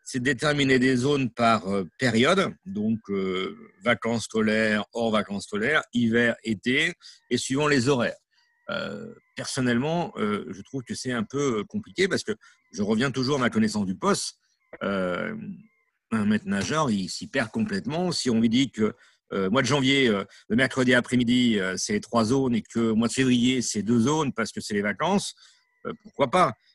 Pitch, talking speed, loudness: 130 Hz, 185 wpm, -25 LUFS